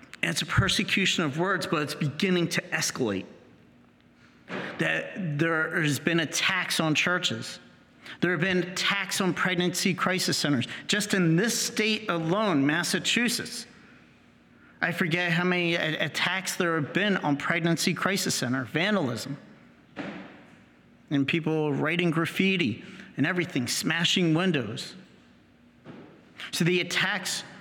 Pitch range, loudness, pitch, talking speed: 155-190 Hz, -26 LUFS, 175 Hz, 120 wpm